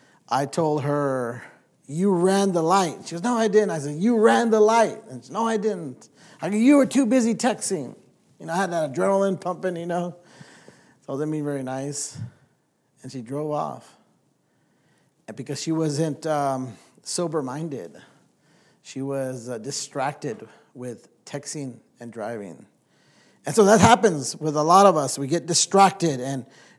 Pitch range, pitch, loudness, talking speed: 140-195 Hz, 155 Hz, -22 LUFS, 170 wpm